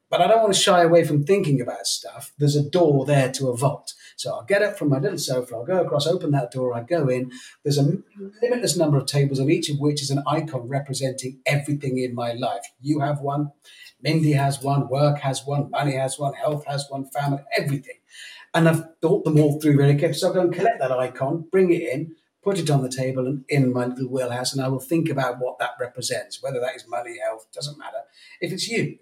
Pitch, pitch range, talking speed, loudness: 145 Hz, 135-165 Hz, 240 wpm, -23 LUFS